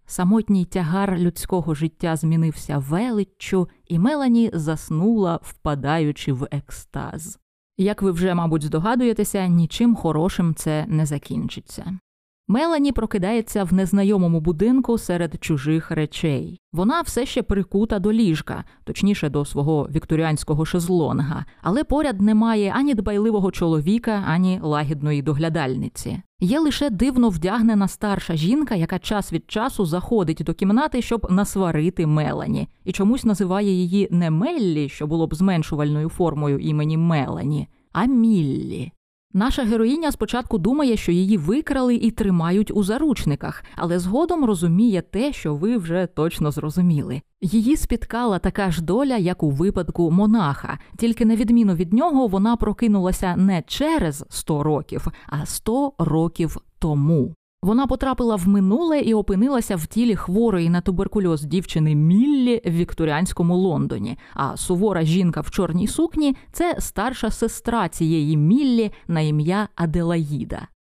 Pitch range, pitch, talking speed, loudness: 160-225 Hz, 185 Hz, 130 wpm, -21 LUFS